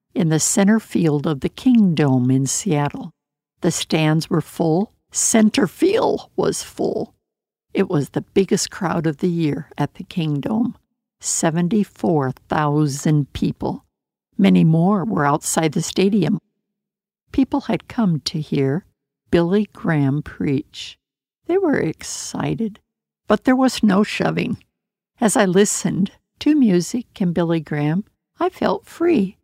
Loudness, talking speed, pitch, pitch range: -19 LUFS, 135 wpm, 180 Hz, 155-210 Hz